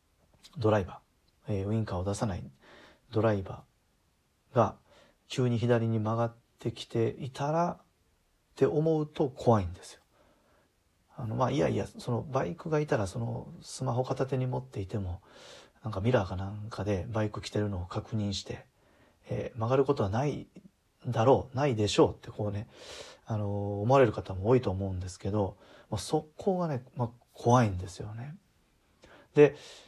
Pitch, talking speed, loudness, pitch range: 115 Hz, 320 characters per minute, -31 LUFS, 100-135 Hz